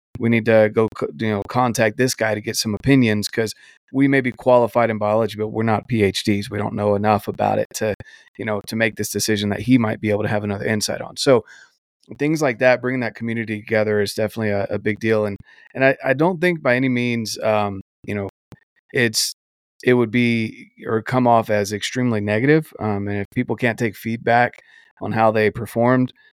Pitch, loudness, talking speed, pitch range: 110 Hz, -20 LUFS, 215 wpm, 105-125 Hz